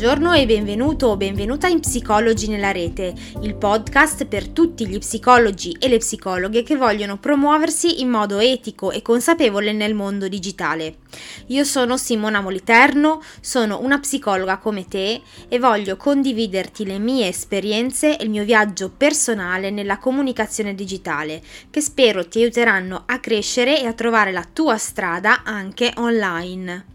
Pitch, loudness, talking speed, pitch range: 220 Hz, -18 LUFS, 145 wpm, 195-255 Hz